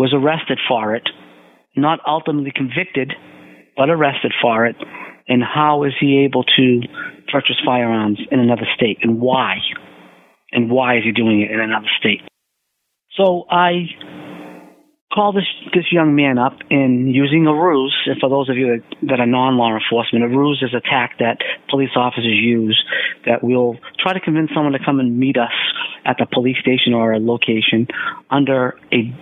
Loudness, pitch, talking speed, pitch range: -16 LUFS, 130 Hz, 170 wpm, 115-145 Hz